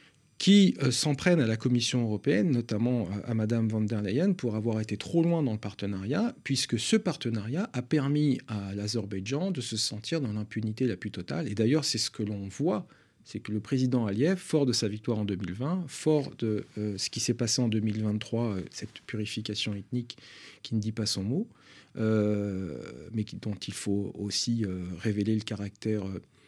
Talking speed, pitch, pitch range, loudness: 195 wpm, 110 Hz, 105-130 Hz, -29 LUFS